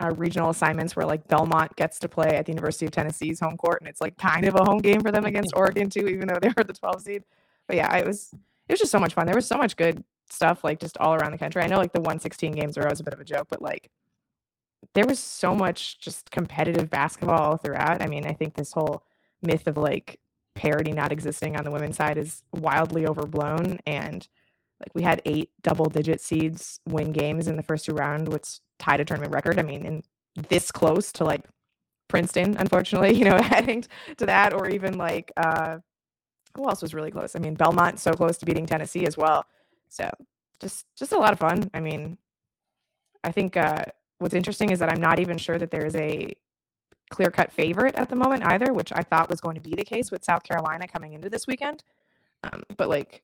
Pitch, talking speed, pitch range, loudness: 165 Hz, 225 wpm, 155-190 Hz, -25 LUFS